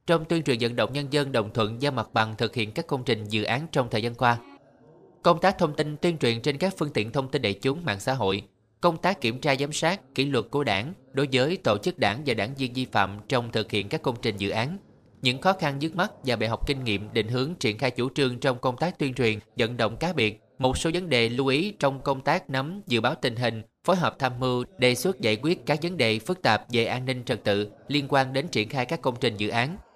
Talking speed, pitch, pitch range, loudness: 270 wpm, 130 Hz, 115-150 Hz, -26 LUFS